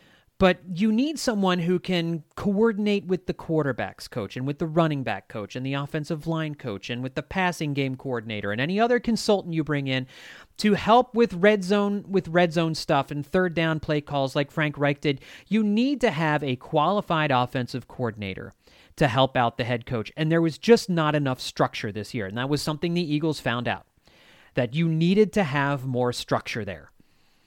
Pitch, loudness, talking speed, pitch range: 155 Hz, -25 LUFS, 200 wpm, 130-185 Hz